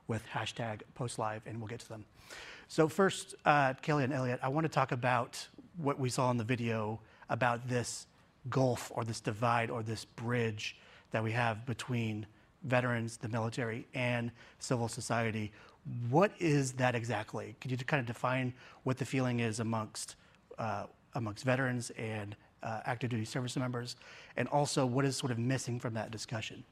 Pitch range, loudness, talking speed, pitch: 115-130 Hz, -35 LUFS, 175 wpm, 120 Hz